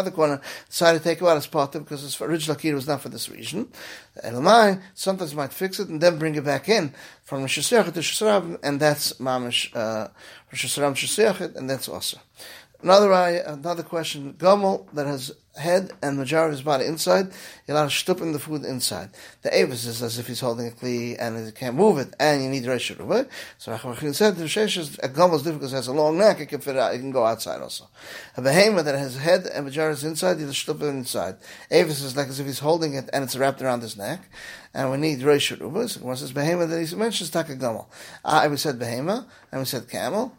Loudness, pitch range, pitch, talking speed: -23 LUFS, 135-170 Hz, 150 Hz, 225 wpm